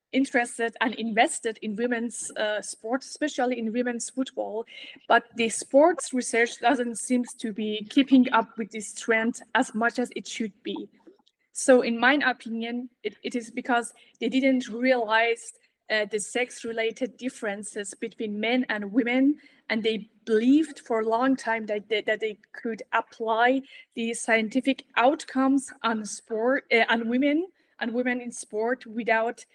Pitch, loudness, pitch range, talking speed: 235 Hz, -26 LUFS, 225-255 Hz, 155 wpm